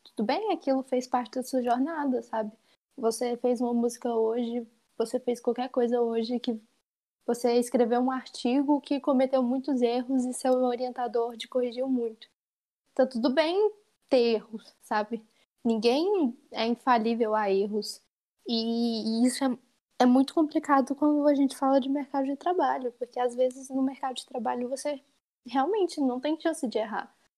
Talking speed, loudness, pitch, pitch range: 160 wpm, -28 LUFS, 250 Hz, 235-275 Hz